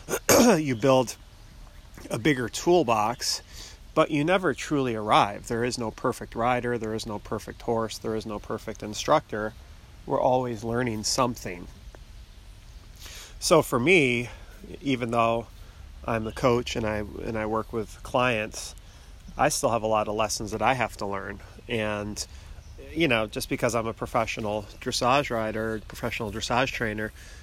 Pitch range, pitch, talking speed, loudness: 105-120 Hz, 110 Hz, 150 wpm, -26 LUFS